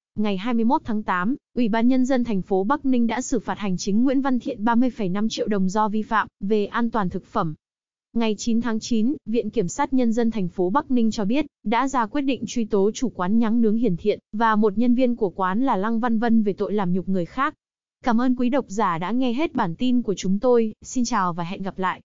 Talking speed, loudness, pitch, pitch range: 255 wpm, -23 LUFS, 225 Hz, 205-245 Hz